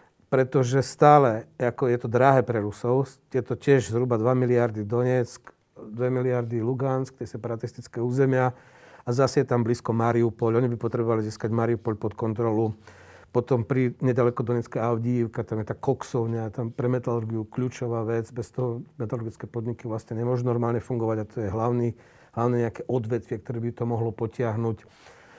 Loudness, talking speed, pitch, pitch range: -26 LUFS, 160 wpm, 120 Hz, 115-125 Hz